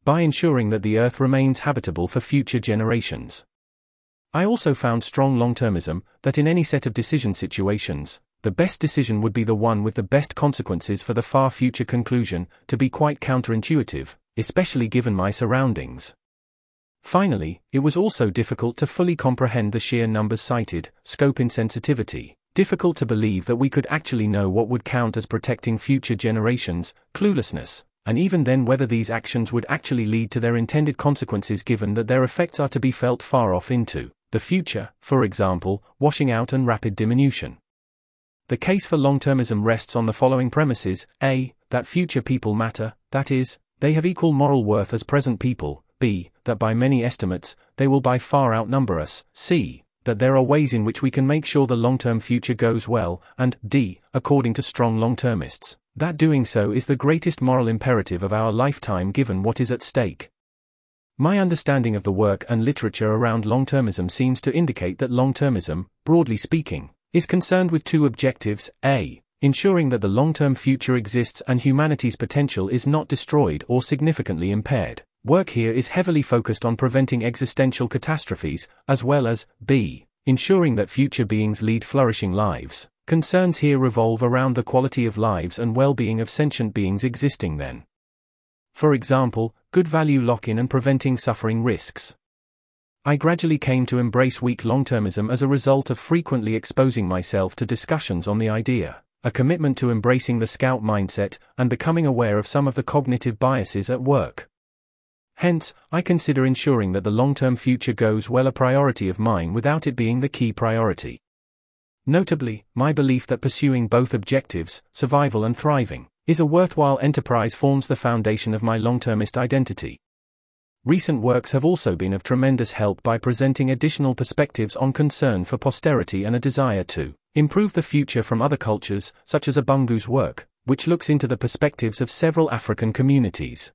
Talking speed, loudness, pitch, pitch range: 175 wpm, -22 LUFS, 125 Hz, 110-140 Hz